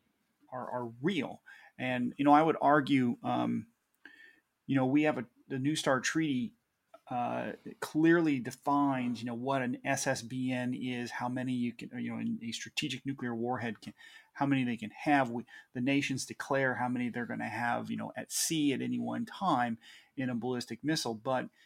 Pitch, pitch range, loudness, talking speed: 130 Hz, 120-150 Hz, -33 LUFS, 185 wpm